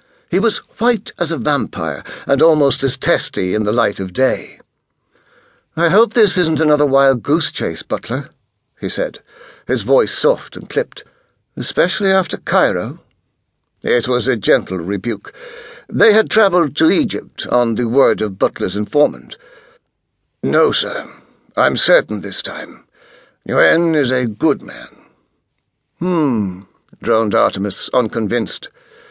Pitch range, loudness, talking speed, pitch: 120-180 Hz, -16 LUFS, 130 wpm, 145 Hz